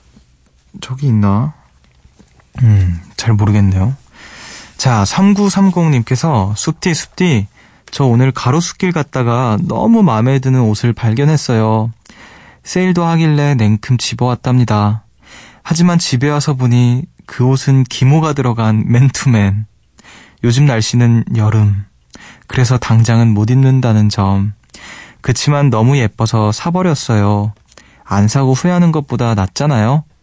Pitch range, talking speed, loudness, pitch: 110-145 Hz, 245 characters per minute, -13 LUFS, 125 Hz